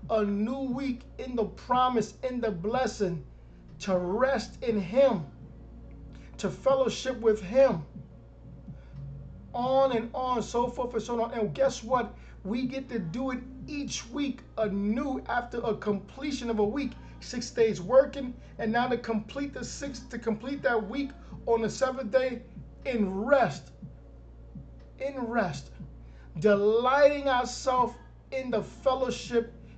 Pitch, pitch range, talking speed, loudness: 235 Hz, 210-260 Hz, 135 wpm, -29 LUFS